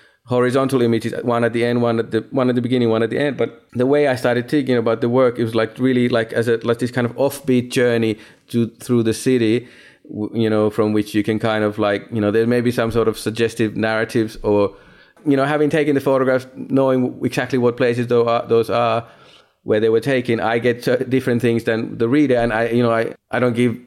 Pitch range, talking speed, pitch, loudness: 115-125 Hz, 240 wpm, 120 Hz, -18 LUFS